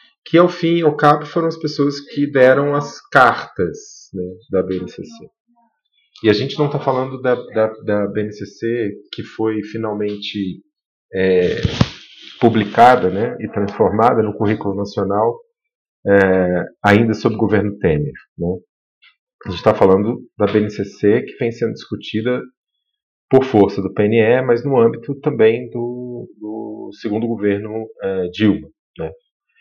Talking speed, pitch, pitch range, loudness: 140 wpm, 115 Hz, 105-145 Hz, -17 LUFS